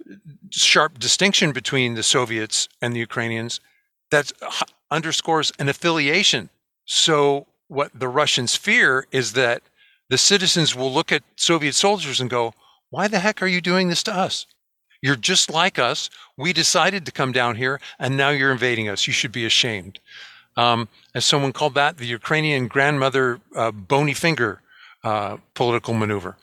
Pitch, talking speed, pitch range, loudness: 140 Hz, 160 wpm, 120-170 Hz, -19 LUFS